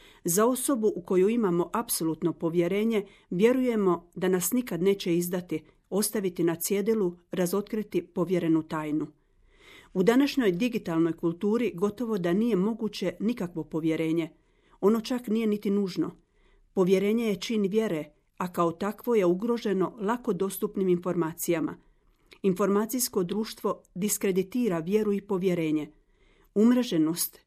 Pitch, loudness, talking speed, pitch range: 195 Hz, -27 LUFS, 115 wpm, 175-215 Hz